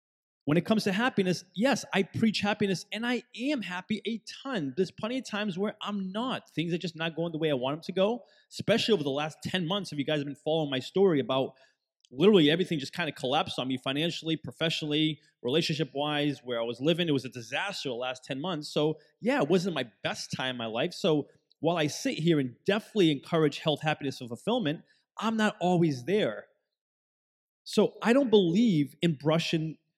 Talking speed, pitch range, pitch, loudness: 210 wpm, 145-200 Hz, 165 Hz, -29 LUFS